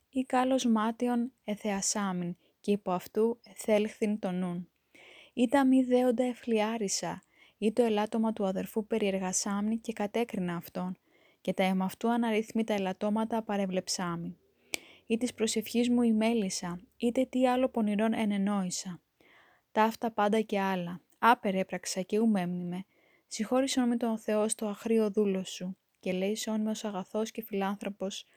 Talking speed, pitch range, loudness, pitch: 130 wpm, 190-230 Hz, -31 LUFS, 215 Hz